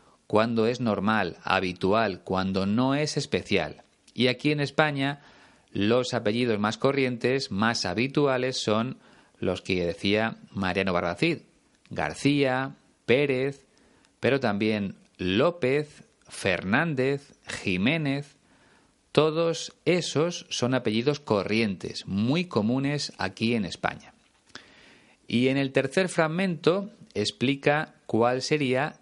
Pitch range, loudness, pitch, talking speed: 110-145 Hz, -26 LUFS, 130 Hz, 100 wpm